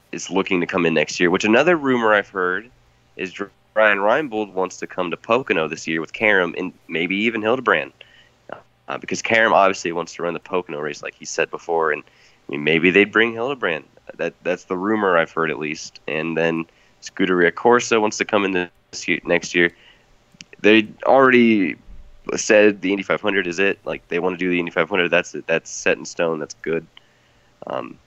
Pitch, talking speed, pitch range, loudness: 95 Hz, 200 wpm, 85-110 Hz, -19 LUFS